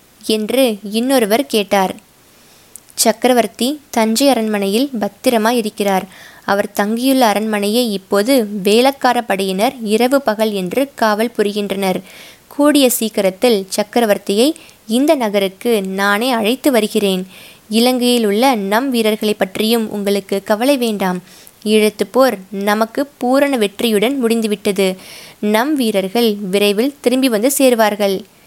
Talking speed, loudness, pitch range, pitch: 95 wpm, -15 LUFS, 205-245 Hz, 220 Hz